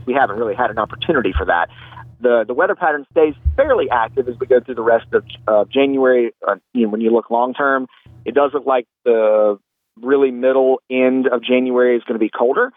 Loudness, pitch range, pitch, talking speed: -17 LUFS, 120-140 Hz, 130 Hz, 220 wpm